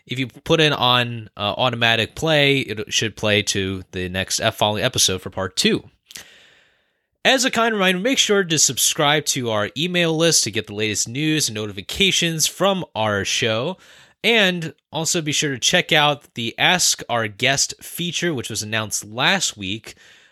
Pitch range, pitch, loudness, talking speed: 110-165 Hz, 130 Hz, -19 LUFS, 170 wpm